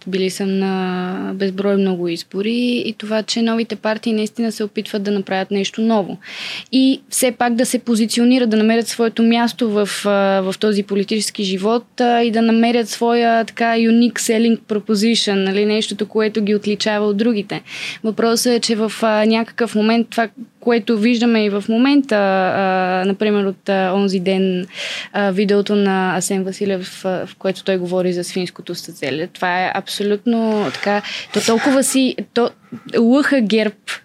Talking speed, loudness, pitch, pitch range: 150 wpm, -17 LUFS, 215 Hz, 195-230 Hz